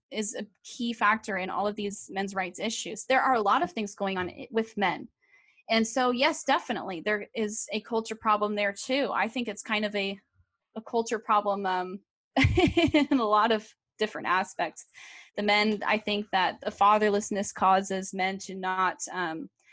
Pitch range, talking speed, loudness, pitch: 195-225 Hz, 185 wpm, -28 LUFS, 210 Hz